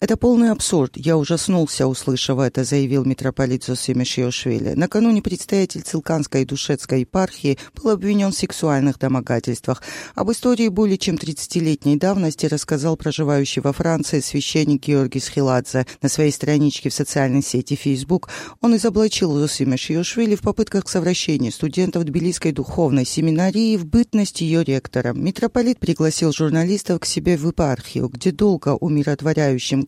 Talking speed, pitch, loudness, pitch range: 135 wpm, 155 Hz, -19 LUFS, 135-185 Hz